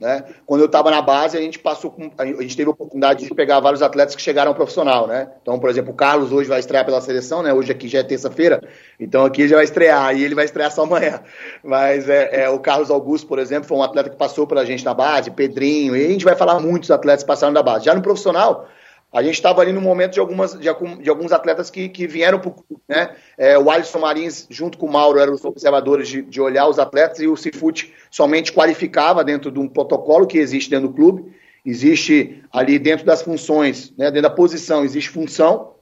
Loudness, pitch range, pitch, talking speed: -16 LUFS, 140-165 Hz, 150 Hz, 240 wpm